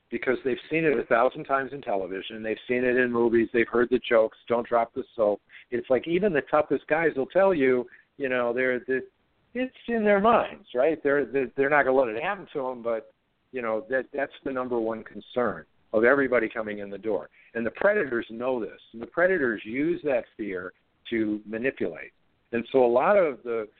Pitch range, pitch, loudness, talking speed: 115-140 Hz, 125 Hz, -26 LUFS, 210 wpm